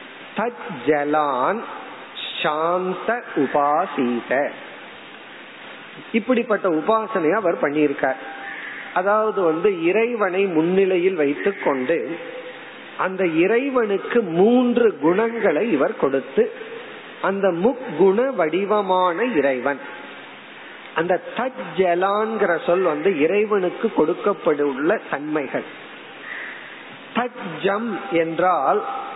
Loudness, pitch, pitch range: -21 LUFS, 195 Hz, 170-235 Hz